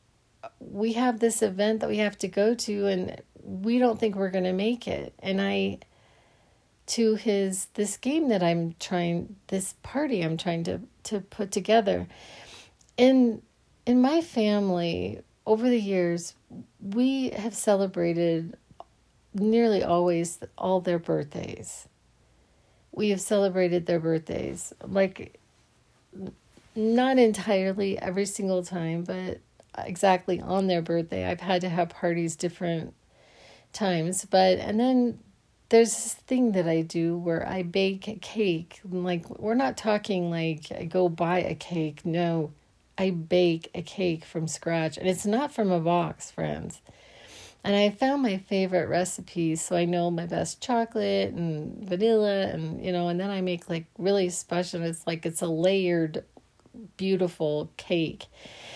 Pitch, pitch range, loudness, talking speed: 185 Hz, 170-210 Hz, -27 LUFS, 145 wpm